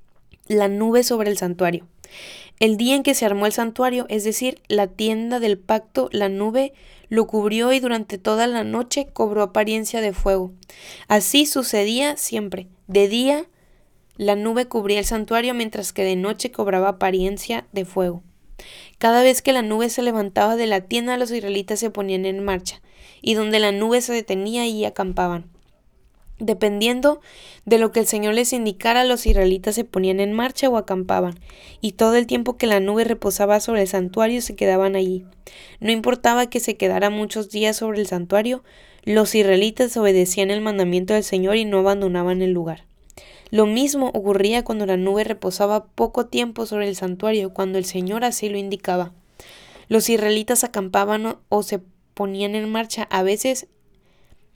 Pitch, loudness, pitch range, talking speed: 215 Hz, -20 LUFS, 195-230 Hz, 170 wpm